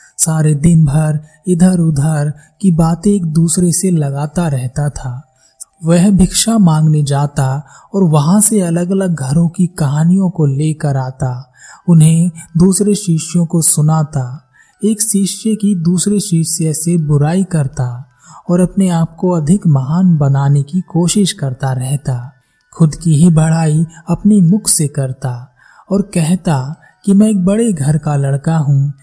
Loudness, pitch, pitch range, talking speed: -13 LUFS, 165 Hz, 145-185 Hz, 145 wpm